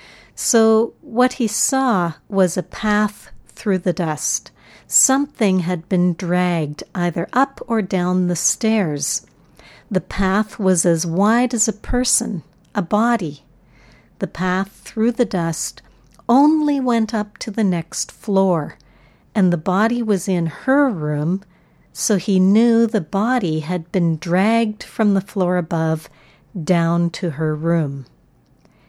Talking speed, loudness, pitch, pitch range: 135 wpm, -19 LUFS, 190 Hz, 170-220 Hz